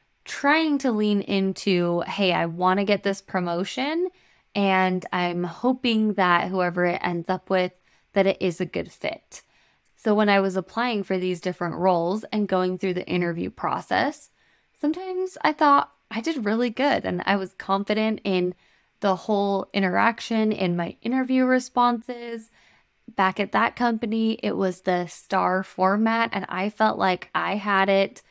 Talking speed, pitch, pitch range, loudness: 160 wpm, 195 Hz, 185-230 Hz, -24 LUFS